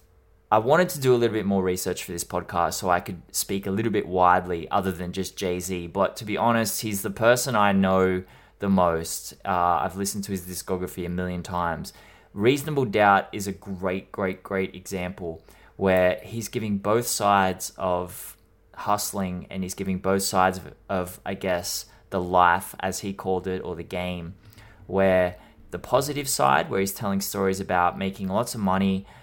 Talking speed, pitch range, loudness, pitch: 185 wpm, 90-100 Hz, -25 LUFS, 95 Hz